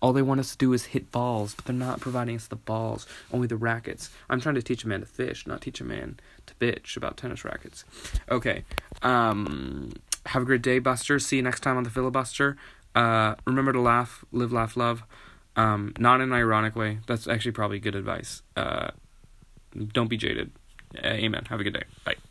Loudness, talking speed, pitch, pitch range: -27 LUFS, 215 wpm, 120 Hz, 110-130 Hz